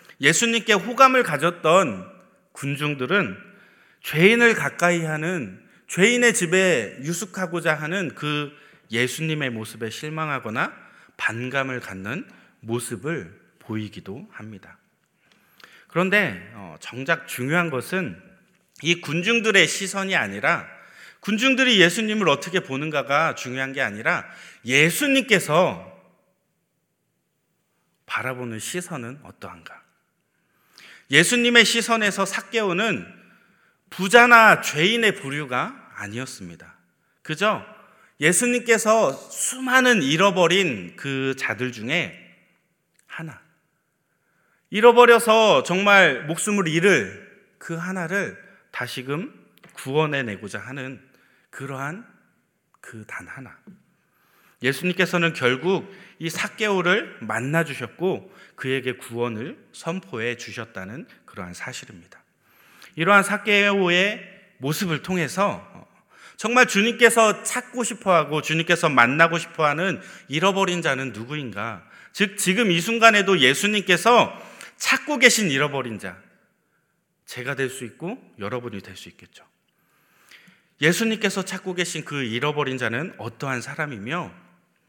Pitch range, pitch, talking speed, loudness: 135-200 Hz, 170 Hz, 245 characters per minute, -20 LUFS